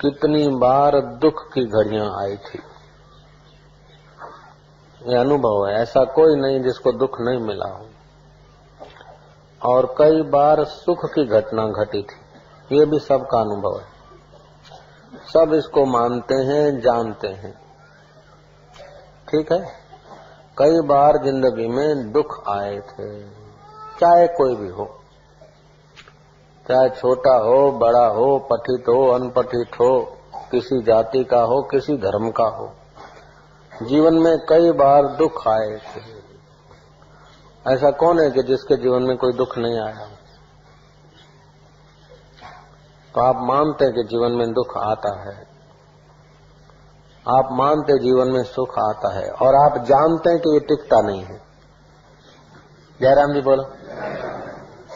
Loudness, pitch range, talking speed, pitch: -18 LUFS, 120-150 Hz, 125 wpm, 130 Hz